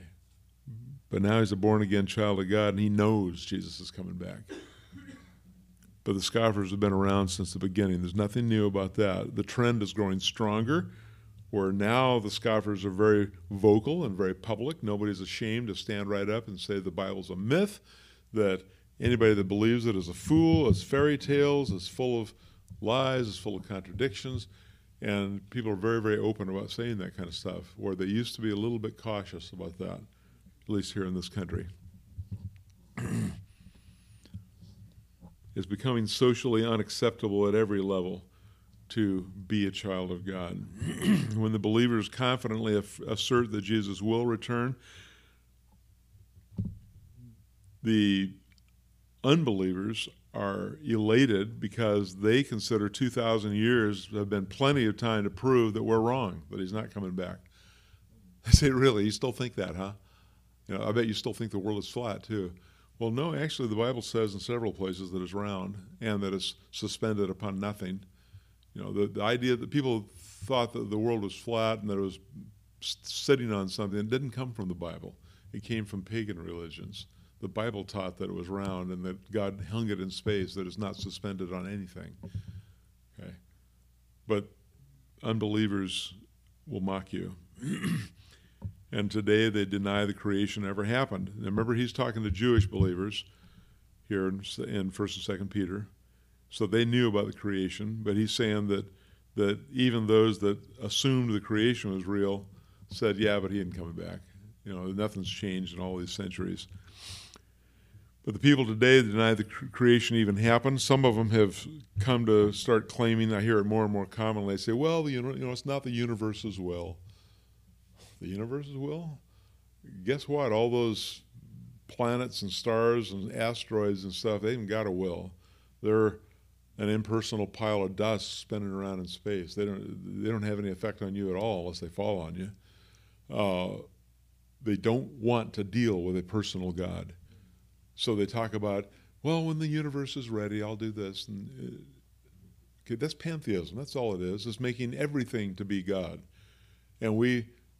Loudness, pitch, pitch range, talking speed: -30 LUFS, 105 Hz, 95-115 Hz, 170 wpm